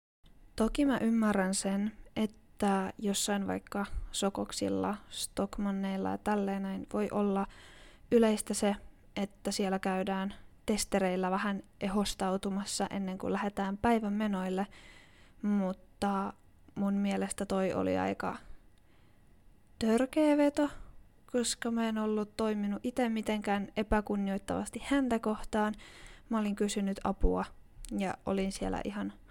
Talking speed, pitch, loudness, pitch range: 110 wpm, 200 Hz, -33 LUFS, 190-215 Hz